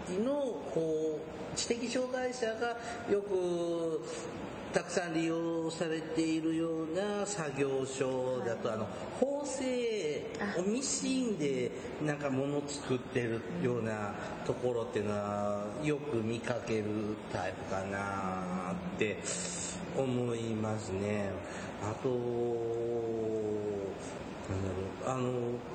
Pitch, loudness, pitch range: 135 Hz, -35 LUFS, 110-170 Hz